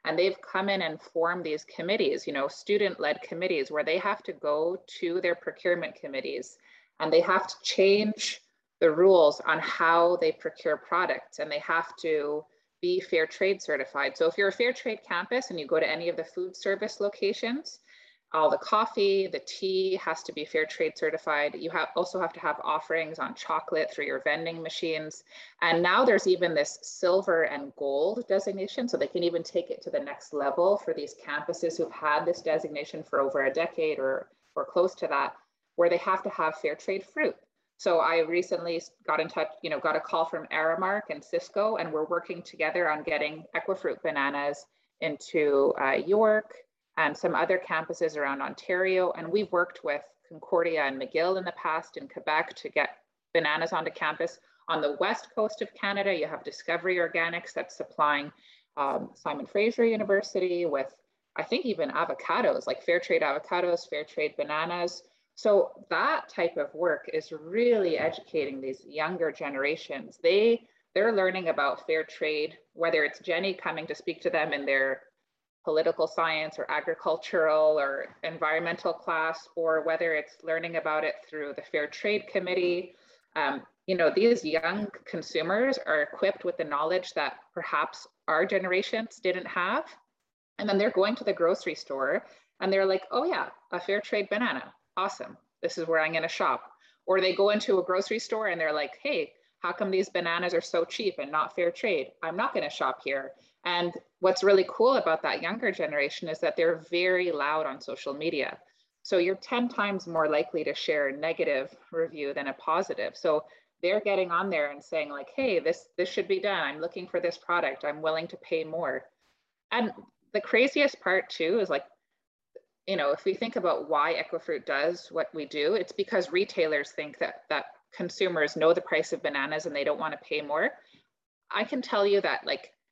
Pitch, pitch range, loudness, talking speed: 175 Hz, 160-210 Hz, -28 LUFS, 190 wpm